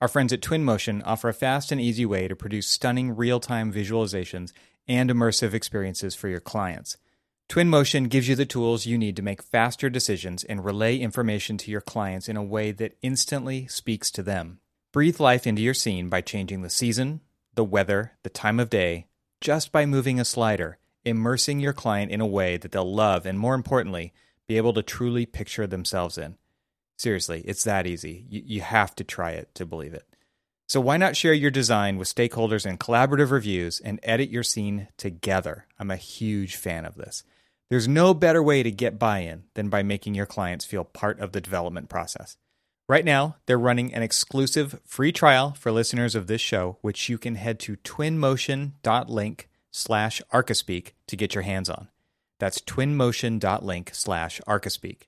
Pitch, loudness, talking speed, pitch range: 110 Hz, -25 LUFS, 185 wpm, 100-125 Hz